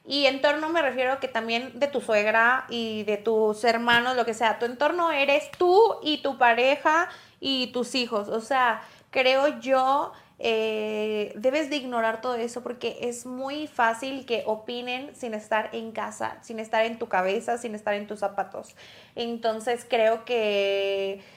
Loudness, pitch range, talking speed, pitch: -25 LUFS, 220-265 Hz, 165 wpm, 235 Hz